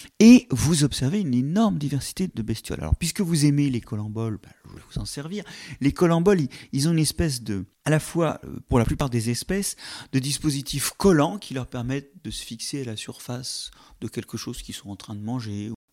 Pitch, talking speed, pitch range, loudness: 135 Hz, 210 wpm, 115-165 Hz, -24 LUFS